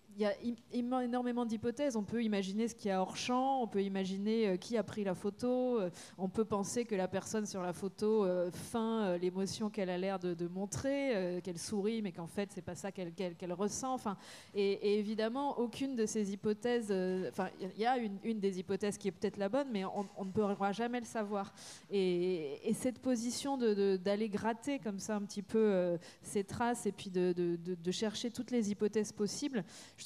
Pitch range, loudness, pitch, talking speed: 190-230 Hz, -37 LUFS, 205 Hz, 230 wpm